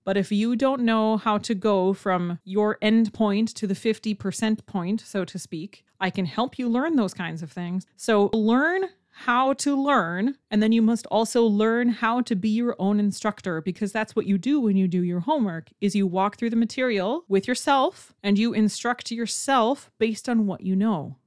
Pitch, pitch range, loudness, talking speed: 215 Hz, 195-235 Hz, -24 LUFS, 205 wpm